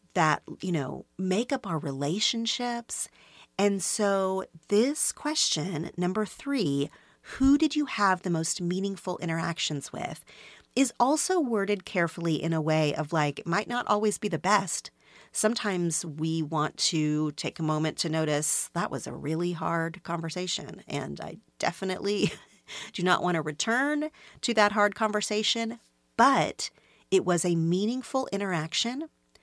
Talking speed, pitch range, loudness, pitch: 145 wpm, 165-215 Hz, -28 LUFS, 190 Hz